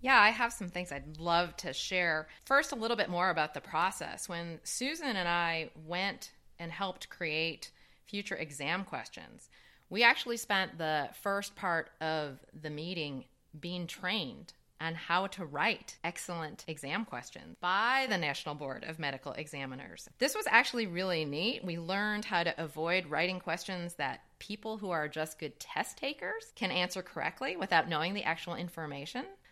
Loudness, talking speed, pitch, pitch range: -34 LUFS, 165 wpm, 175 Hz, 160-205 Hz